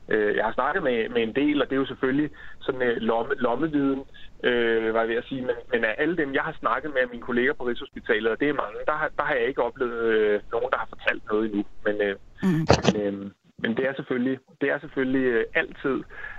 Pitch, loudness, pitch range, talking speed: 130 Hz, -25 LUFS, 115-165 Hz, 235 wpm